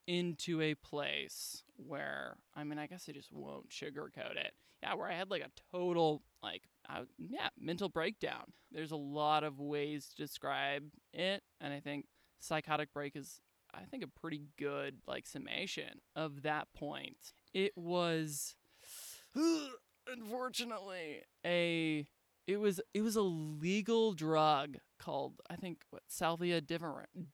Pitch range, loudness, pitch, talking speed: 150-180 Hz, -40 LUFS, 160 Hz, 145 wpm